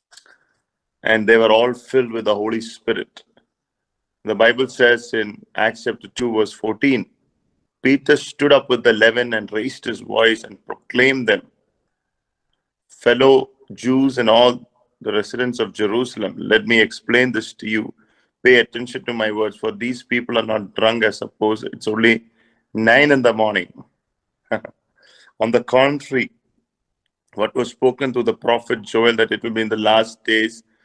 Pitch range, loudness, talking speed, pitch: 110-125 Hz, -18 LUFS, 160 wpm, 115 Hz